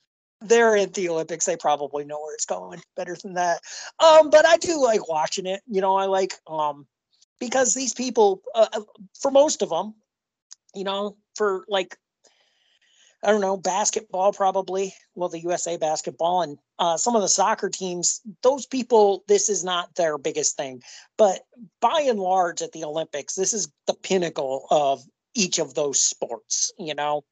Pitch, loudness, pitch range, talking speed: 190 Hz, -22 LUFS, 165-220 Hz, 175 wpm